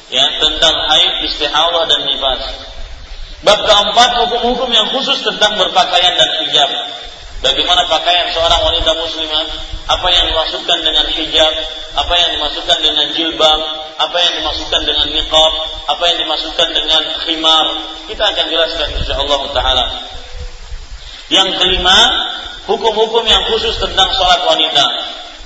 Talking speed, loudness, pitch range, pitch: 125 wpm, -11 LUFS, 155-190 Hz, 160 Hz